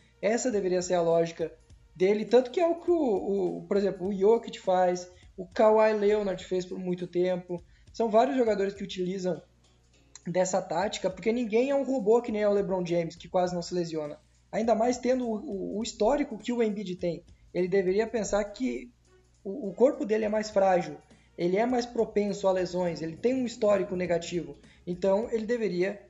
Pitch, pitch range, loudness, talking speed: 195 Hz, 180-225 Hz, -28 LUFS, 190 wpm